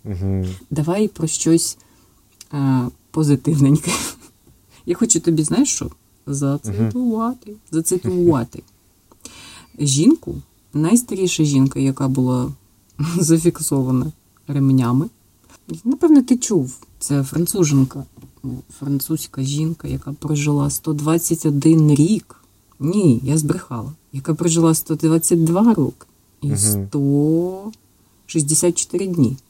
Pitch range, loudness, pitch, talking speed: 130-170 Hz, -18 LUFS, 150 Hz, 80 wpm